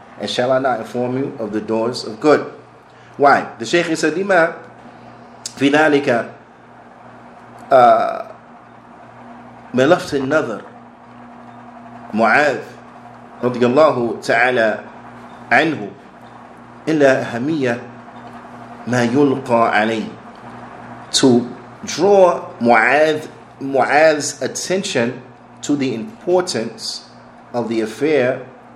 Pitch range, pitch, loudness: 120-160 Hz, 135 Hz, -16 LUFS